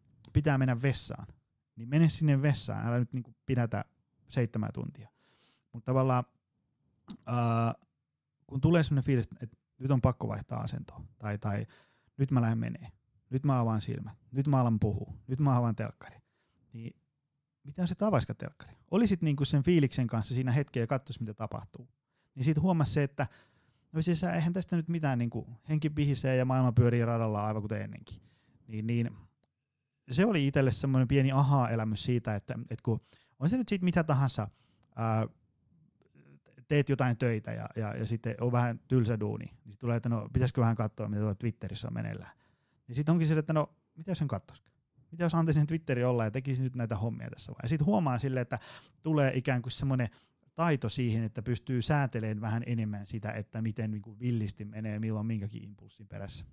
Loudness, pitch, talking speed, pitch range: -31 LUFS, 125 Hz, 180 wpm, 110-140 Hz